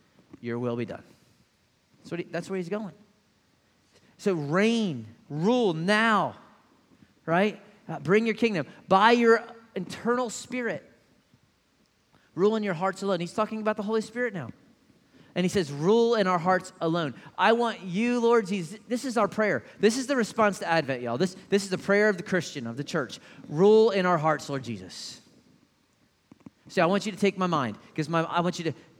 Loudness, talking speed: -26 LUFS, 185 wpm